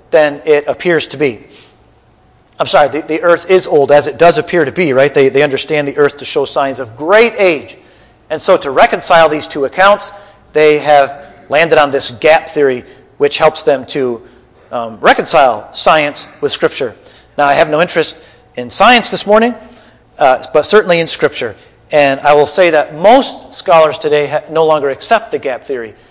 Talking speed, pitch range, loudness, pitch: 190 wpm, 140-175 Hz, -11 LUFS, 155 Hz